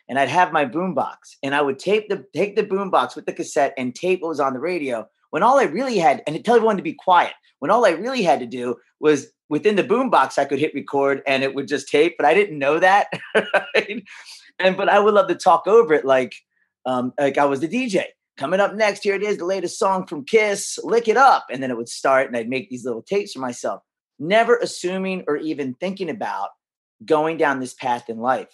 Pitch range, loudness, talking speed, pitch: 135-195 Hz, -20 LUFS, 240 wpm, 155 Hz